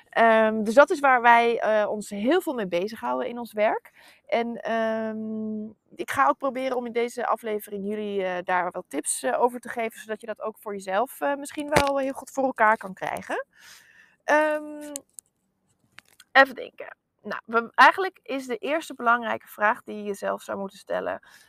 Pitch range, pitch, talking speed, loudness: 215-275 Hz, 230 Hz, 185 wpm, -24 LUFS